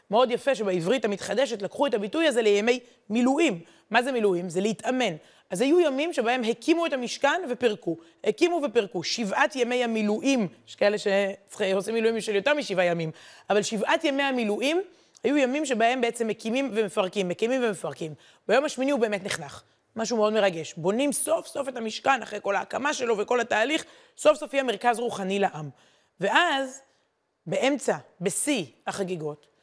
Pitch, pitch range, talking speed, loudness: 230 Hz, 200-270 Hz, 160 wpm, -26 LUFS